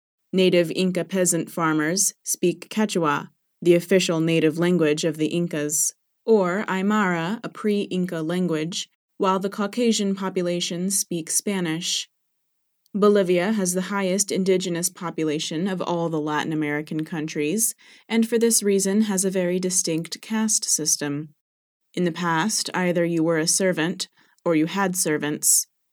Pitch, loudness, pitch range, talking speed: 180 Hz, -22 LUFS, 165-195 Hz, 135 wpm